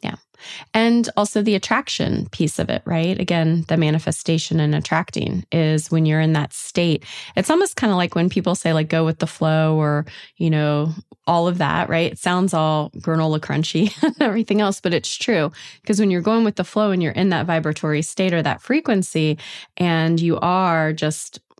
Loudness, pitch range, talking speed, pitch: -20 LUFS, 155-200 Hz, 195 wpm, 165 Hz